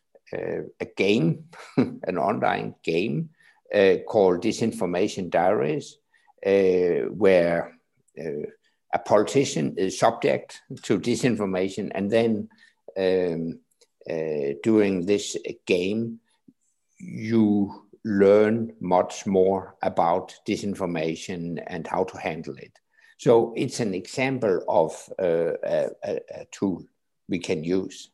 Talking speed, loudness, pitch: 105 wpm, -24 LUFS, 115 Hz